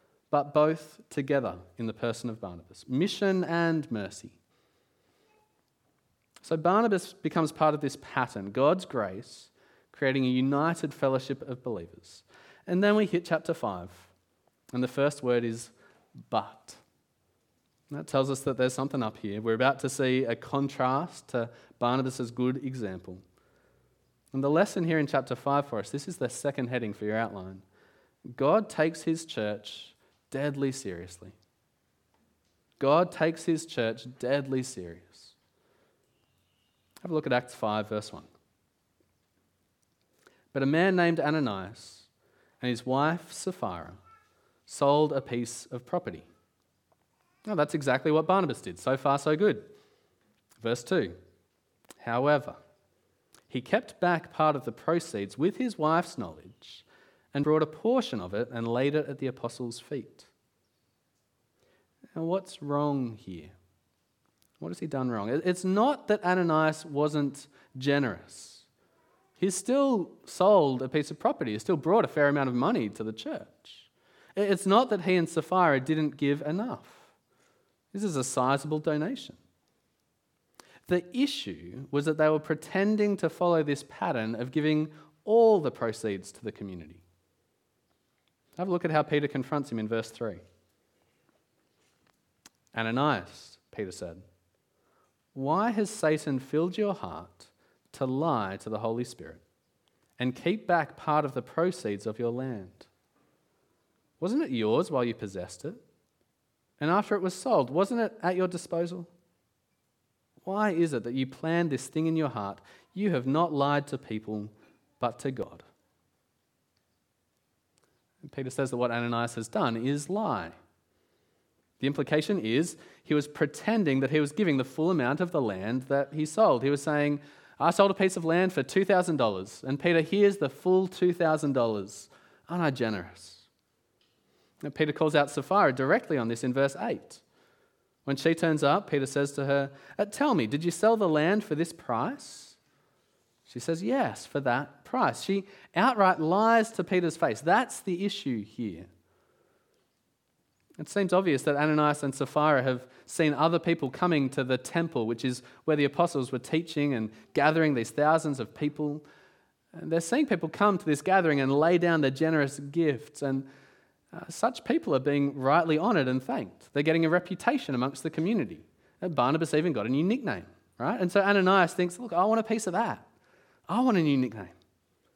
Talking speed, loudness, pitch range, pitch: 155 wpm, -28 LUFS, 120-170 Hz, 145 Hz